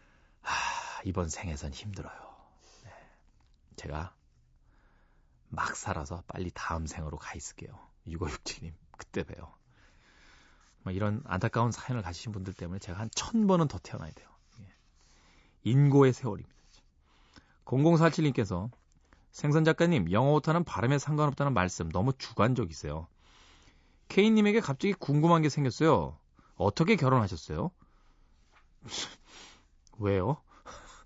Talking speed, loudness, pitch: 260 characters per minute, -30 LUFS, 100 Hz